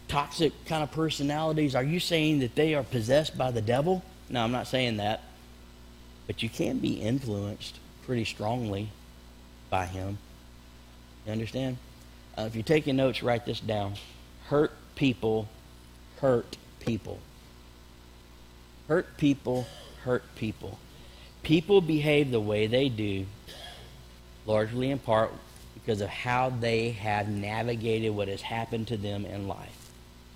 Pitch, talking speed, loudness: 110 Hz, 135 wpm, -29 LUFS